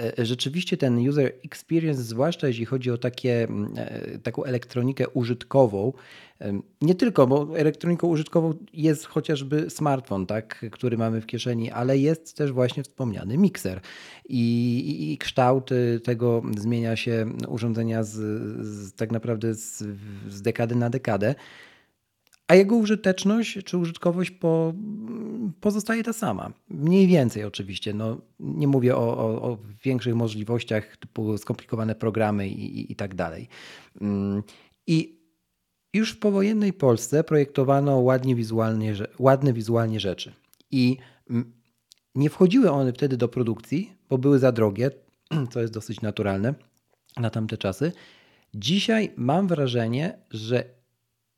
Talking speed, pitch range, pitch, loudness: 130 wpm, 115-155 Hz, 125 Hz, -25 LUFS